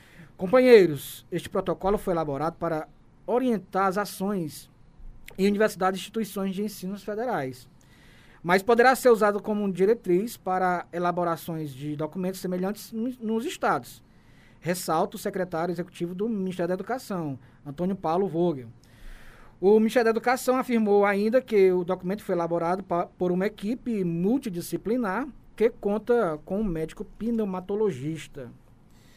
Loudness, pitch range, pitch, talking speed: -26 LUFS, 170-215 Hz, 190 Hz, 125 wpm